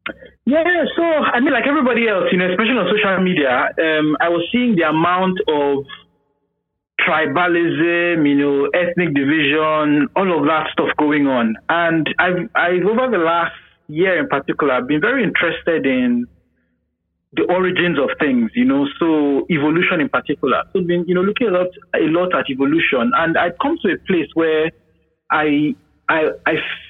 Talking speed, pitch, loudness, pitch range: 170 wpm, 170 Hz, -16 LUFS, 145-185 Hz